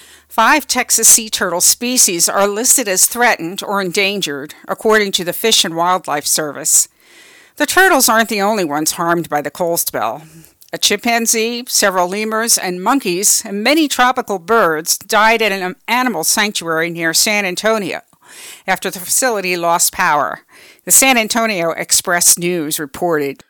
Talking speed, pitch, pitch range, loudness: 150 wpm, 200 Hz, 175-225 Hz, -13 LUFS